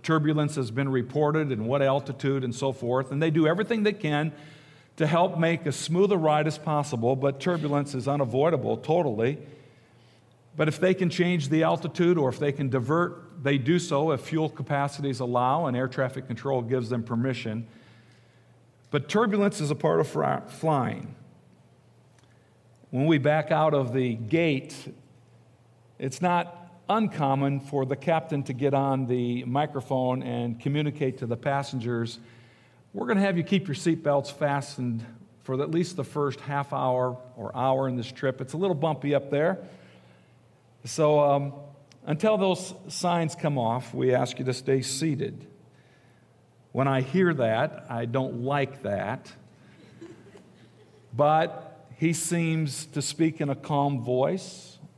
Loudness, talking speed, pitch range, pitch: -27 LUFS, 155 wpm, 125-155 Hz, 140 Hz